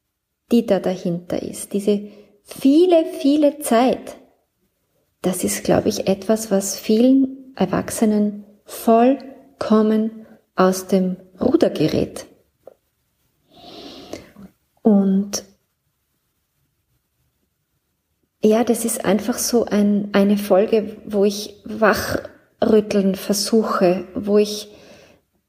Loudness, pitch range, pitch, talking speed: -19 LUFS, 200-235 Hz, 215 Hz, 85 wpm